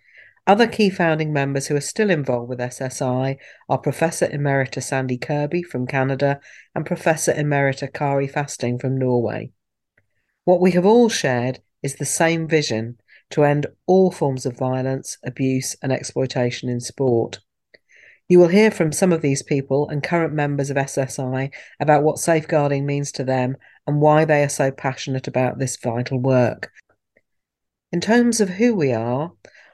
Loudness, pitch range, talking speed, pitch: -20 LUFS, 130-155 Hz, 160 wpm, 140 Hz